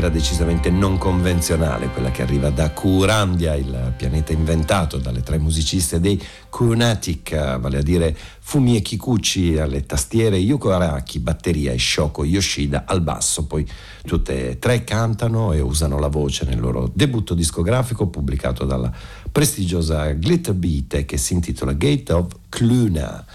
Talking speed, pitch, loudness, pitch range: 145 wpm, 85 Hz, -20 LUFS, 70-95 Hz